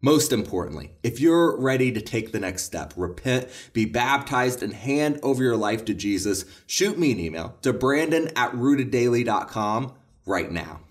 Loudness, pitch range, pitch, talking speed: -24 LUFS, 100-130 Hz, 120 Hz, 165 wpm